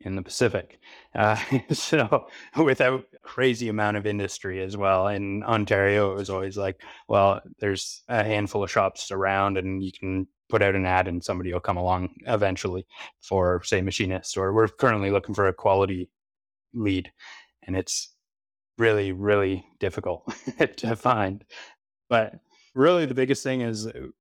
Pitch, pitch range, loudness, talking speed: 100 Hz, 95-105 Hz, -25 LUFS, 155 wpm